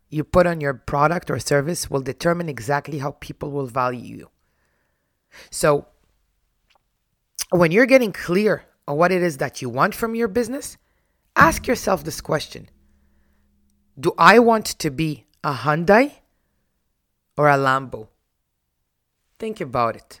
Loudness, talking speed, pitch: -20 LUFS, 140 wpm, 145 Hz